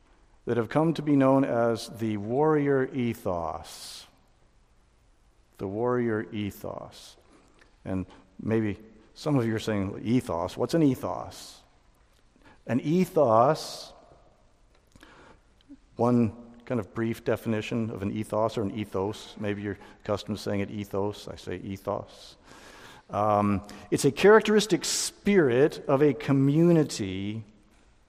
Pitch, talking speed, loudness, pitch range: 110 Hz, 120 wpm, -27 LUFS, 105-135 Hz